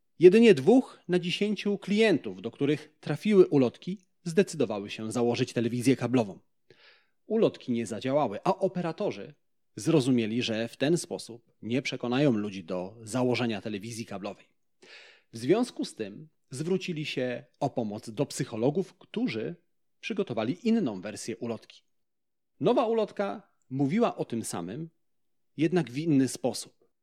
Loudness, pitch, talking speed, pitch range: -28 LUFS, 145 Hz, 125 wpm, 115-180 Hz